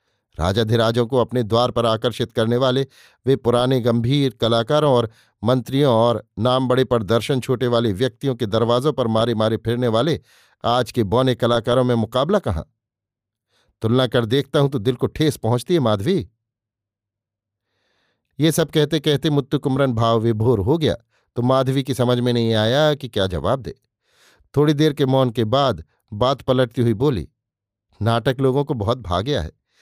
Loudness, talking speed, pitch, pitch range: -19 LUFS, 165 wpm, 120 Hz, 115-135 Hz